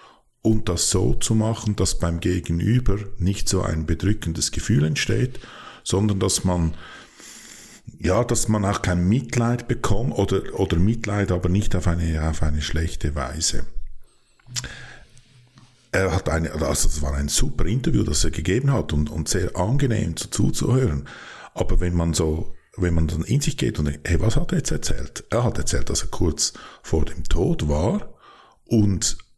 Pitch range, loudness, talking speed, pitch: 80-110 Hz, -23 LUFS, 170 wpm, 90 Hz